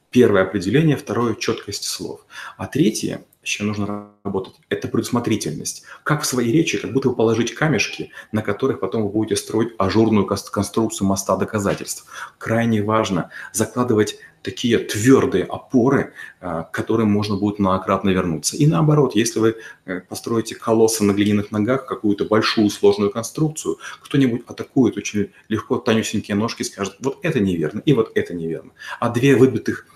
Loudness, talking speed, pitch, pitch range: -20 LUFS, 150 wpm, 110 Hz, 100-125 Hz